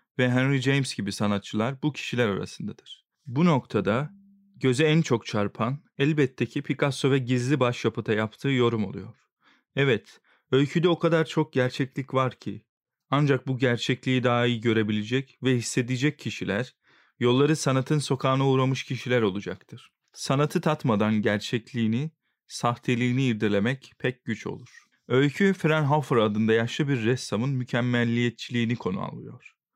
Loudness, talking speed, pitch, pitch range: -25 LUFS, 130 wpm, 130 Hz, 115-140 Hz